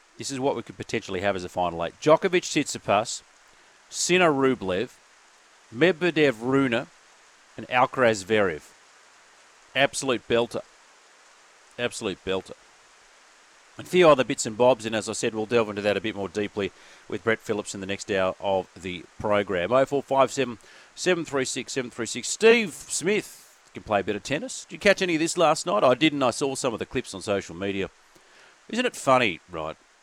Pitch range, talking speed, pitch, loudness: 100-140 Hz, 175 wpm, 120 Hz, -25 LUFS